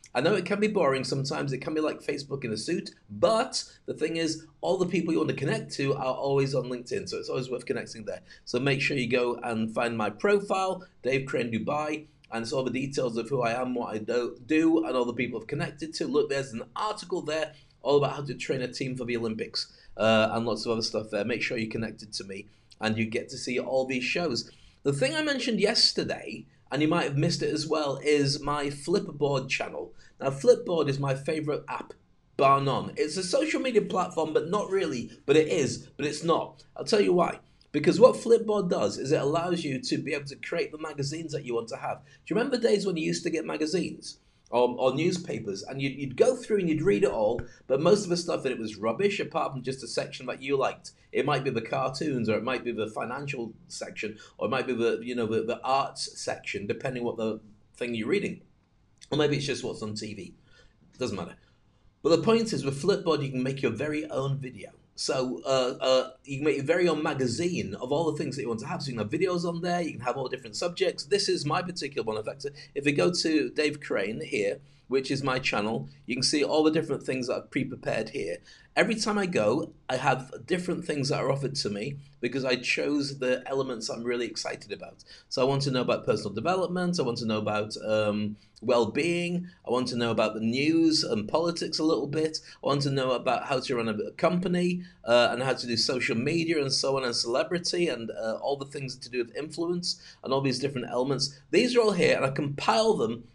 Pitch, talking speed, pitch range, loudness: 140 Hz, 240 wpm, 125-170 Hz, -28 LUFS